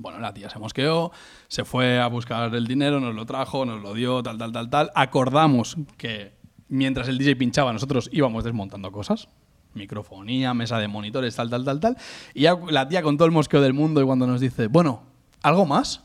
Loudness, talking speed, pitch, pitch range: -23 LUFS, 205 wpm, 130 Hz, 115-145 Hz